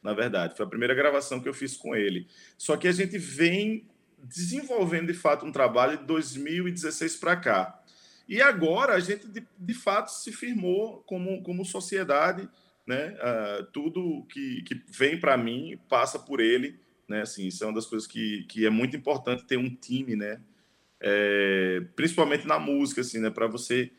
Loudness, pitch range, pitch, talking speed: -28 LUFS, 125-195 Hz, 155 Hz, 180 wpm